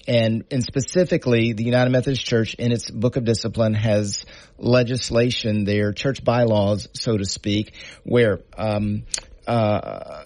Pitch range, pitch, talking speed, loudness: 105-125 Hz, 115 Hz, 135 wpm, -21 LUFS